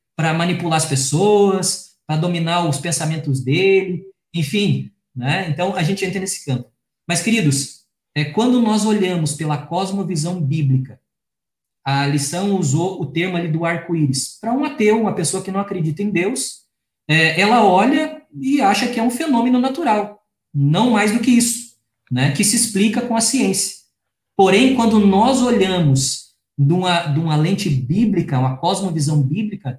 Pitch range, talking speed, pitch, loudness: 150-210 Hz, 155 wpm, 180 Hz, -18 LUFS